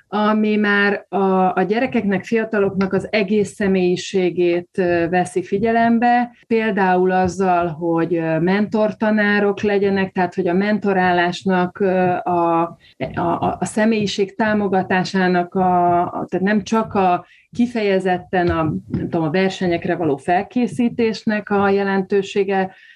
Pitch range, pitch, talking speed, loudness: 180-210 Hz, 190 Hz, 105 wpm, -18 LUFS